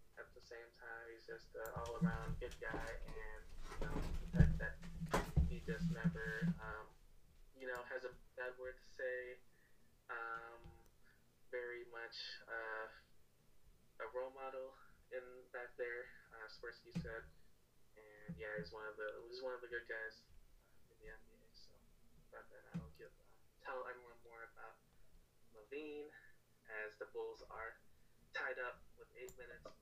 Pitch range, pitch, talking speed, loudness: 110-130 Hz, 120 Hz, 150 wpm, -47 LUFS